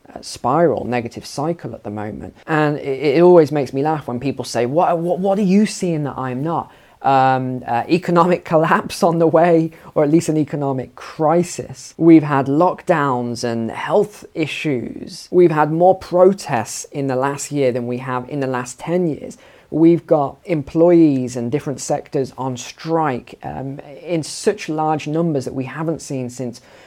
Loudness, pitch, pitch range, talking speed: -18 LUFS, 150 Hz, 130-170 Hz, 175 wpm